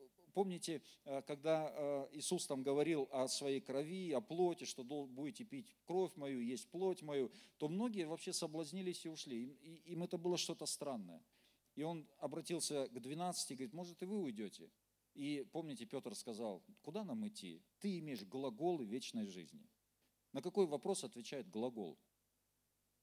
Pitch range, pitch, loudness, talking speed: 140-185 Hz, 165 Hz, -44 LUFS, 150 wpm